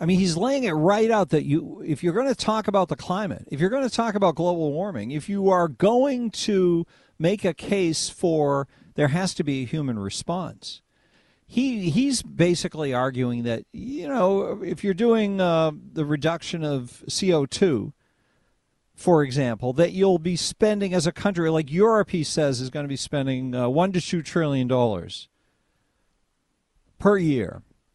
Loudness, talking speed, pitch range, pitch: -23 LUFS, 170 wpm, 145-195 Hz, 170 Hz